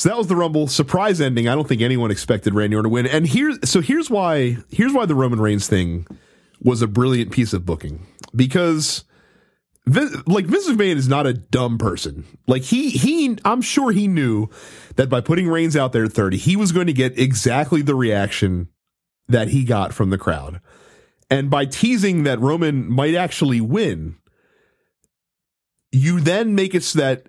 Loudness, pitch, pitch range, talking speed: -19 LUFS, 130 Hz, 115-170 Hz, 185 wpm